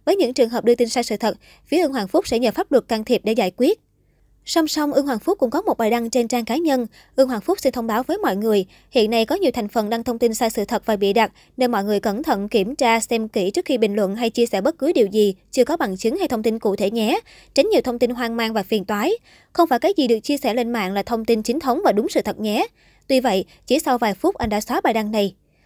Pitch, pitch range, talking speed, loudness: 235 Hz, 220-265 Hz, 305 wpm, -20 LUFS